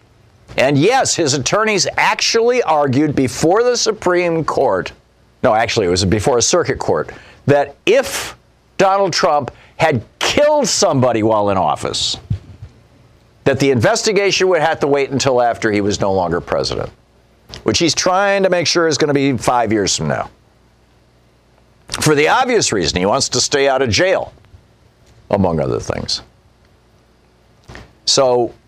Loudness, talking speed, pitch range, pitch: -15 LUFS, 150 wpm, 105-165 Hz, 125 Hz